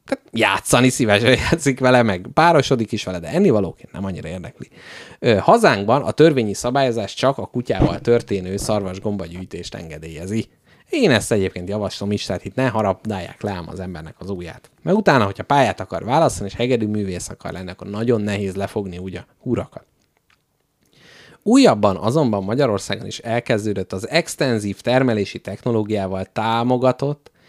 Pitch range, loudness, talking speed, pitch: 95-125 Hz, -19 LUFS, 150 wpm, 105 Hz